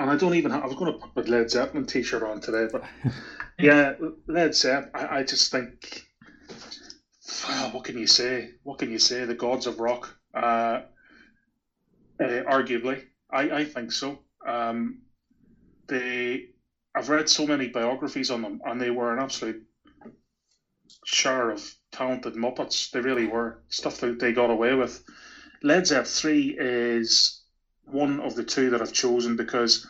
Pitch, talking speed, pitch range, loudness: 125 Hz, 165 wpm, 120-140 Hz, -25 LUFS